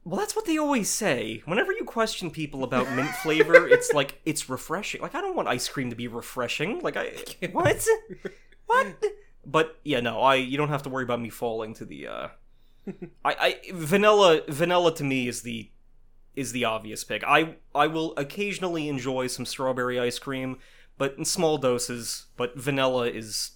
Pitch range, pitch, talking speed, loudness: 125-185 Hz, 140 Hz, 185 wpm, -25 LUFS